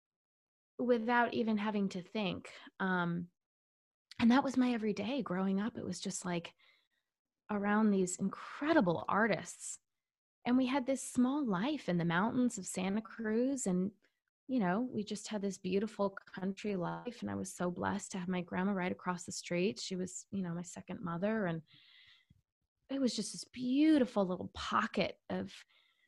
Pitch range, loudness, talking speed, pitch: 185-245 Hz, -35 LUFS, 165 wpm, 205 Hz